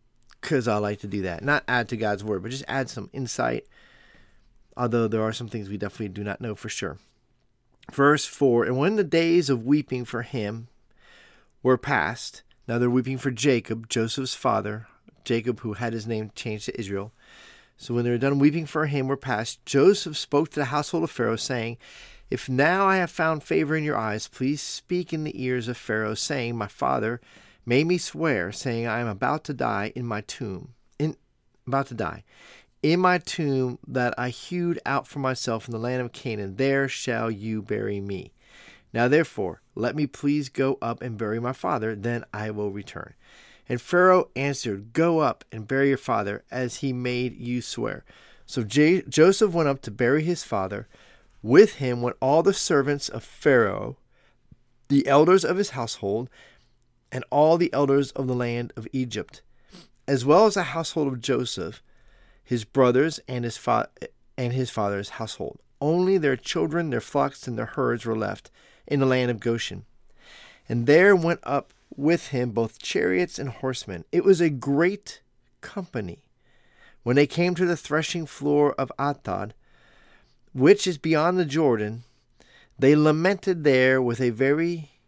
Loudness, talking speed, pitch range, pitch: -24 LUFS, 180 wpm, 115-150 Hz, 130 Hz